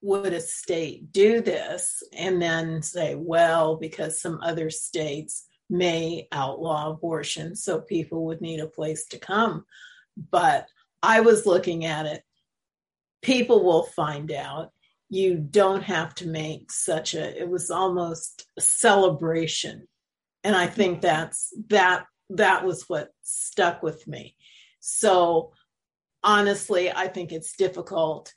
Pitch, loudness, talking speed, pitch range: 175 Hz, -24 LUFS, 135 wpm, 160-195 Hz